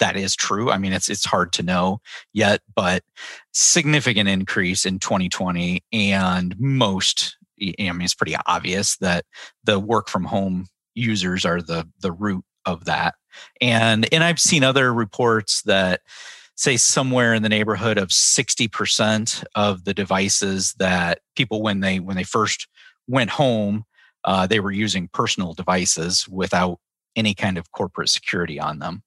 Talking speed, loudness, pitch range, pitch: 155 wpm, -20 LUFS, 90-110 Hz, 100 Hz